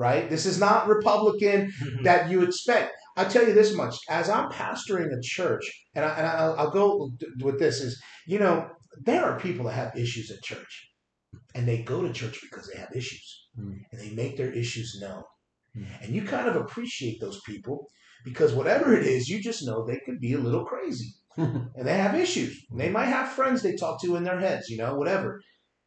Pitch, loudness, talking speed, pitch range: 160 Hz, -26 LUFS, 210 wpm, 120-200 Hz